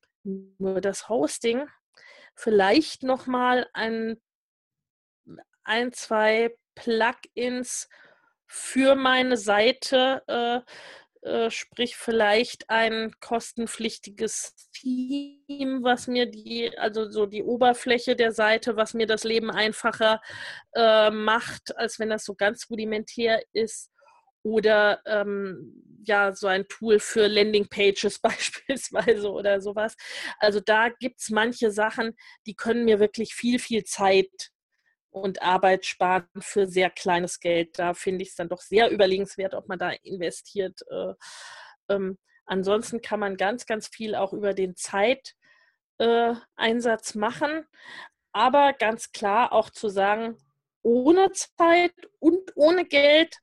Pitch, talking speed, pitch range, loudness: 225 Hz, 125 wpm, 205-250 Hz, -24 LUFS